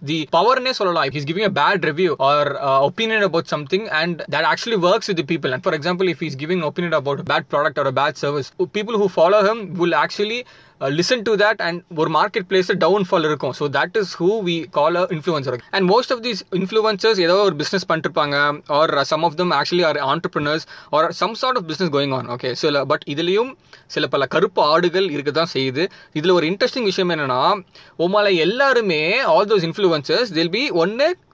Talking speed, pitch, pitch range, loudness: 205 wpm, 175 Hz, 155-205 Hz, -19 LUFS